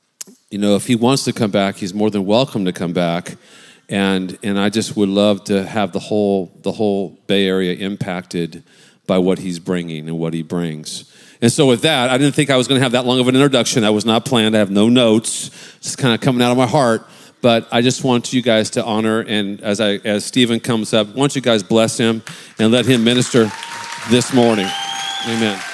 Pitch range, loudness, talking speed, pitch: 100-125 Hz, -16 LUFS, 230 wpm, 110 Hz